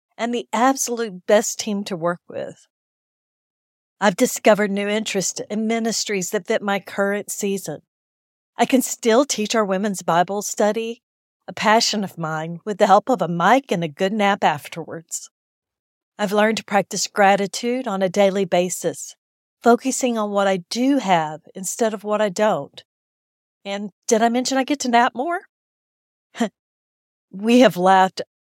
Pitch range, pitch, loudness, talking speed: 190-230 Hz, 210 Hz, -20 LUFS, 160 wpm